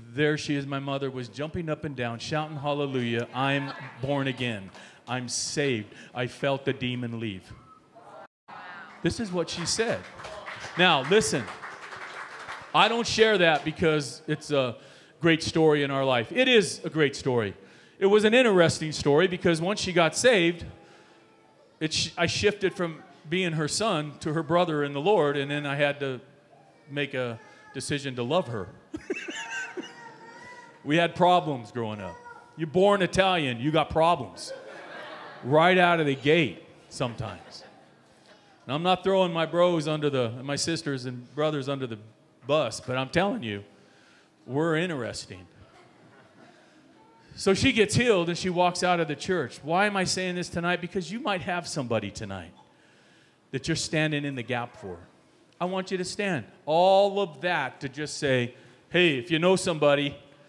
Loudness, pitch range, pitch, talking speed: -26 LUFS, 135-180 Hz, 155 Hz, 165 wpm